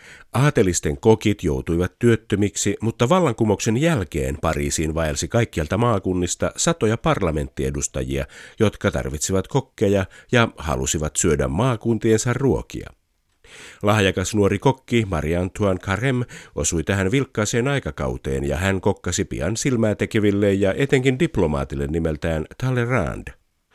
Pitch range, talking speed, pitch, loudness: 80-115 Hz, 105 wpm, 100 Hz, -21 LUFS